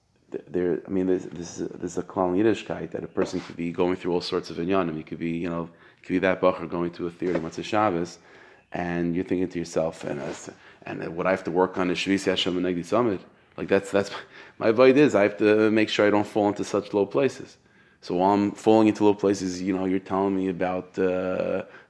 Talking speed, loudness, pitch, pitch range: 250 wpm, -25 LUFS, 95 Hz, 90-100 Hz